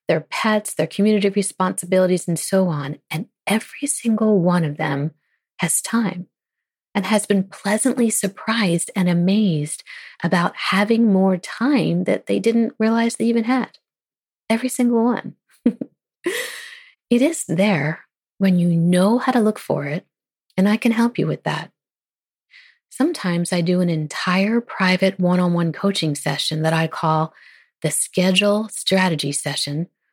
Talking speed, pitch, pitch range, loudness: 145 wpm, 195 Hz, 175-230 Hz, -20 LUFS